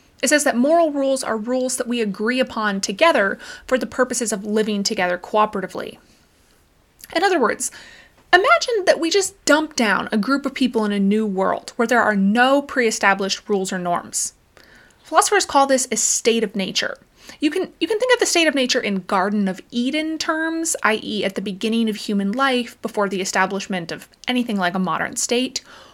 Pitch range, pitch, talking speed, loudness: 205-290 Hz, 240 Hz, 190 wpm, -19 LUFS